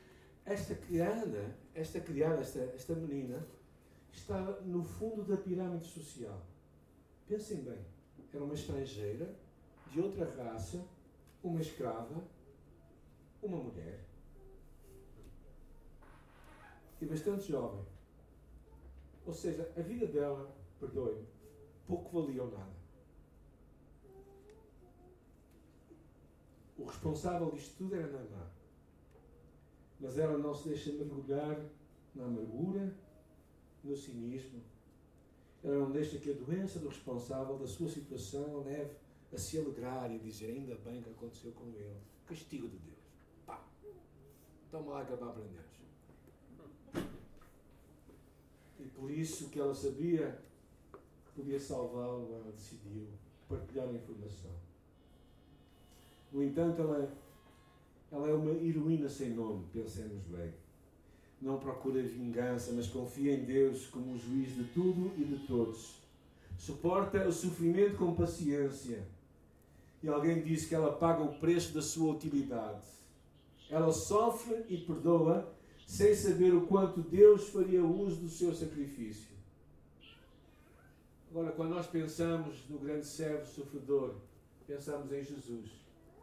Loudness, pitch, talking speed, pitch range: -37 LUFS, 135 Hz, 115 wpm, 100-160 Hz